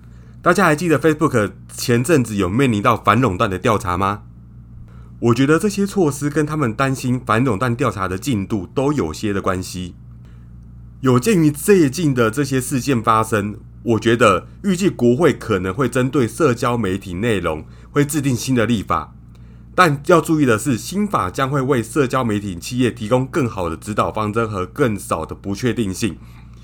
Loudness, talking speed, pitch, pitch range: -18 LUFS, 280 characters per minute, 115 Hz, 95-140 Hz